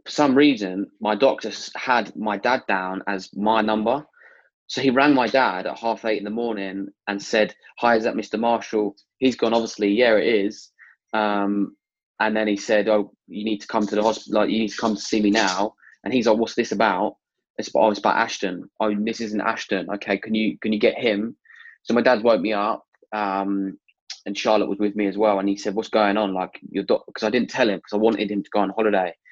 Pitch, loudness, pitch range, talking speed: 105 Hz, -22 LUFS, 100-110 Hz, 240 wpm